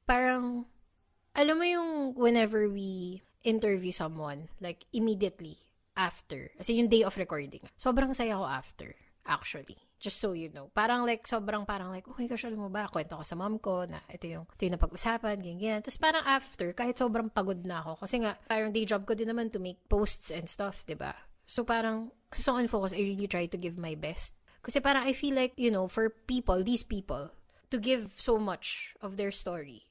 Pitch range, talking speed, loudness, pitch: 185-240 Hz, 195 wpm, -31 LUFS, 210 Hz